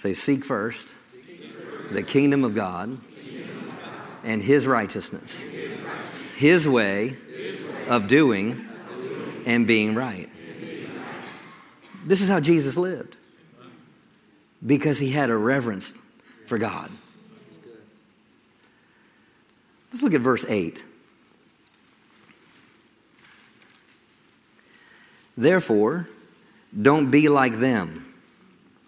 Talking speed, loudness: 80 wpm, -23 LUFS